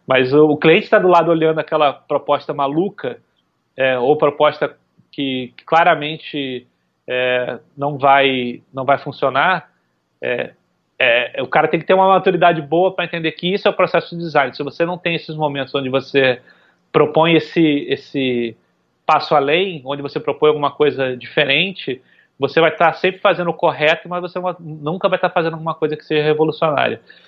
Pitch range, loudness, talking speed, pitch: 140-170 Hz, -17 LUFS, 175 wpm, 155 Hz